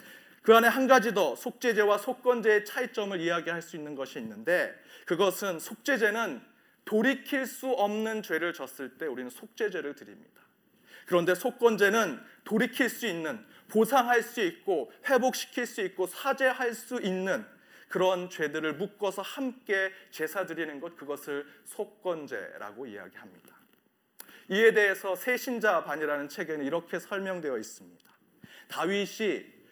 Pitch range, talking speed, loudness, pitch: 180-250 Hz, 305 characters per minute, -29 LUFS, 210 Hz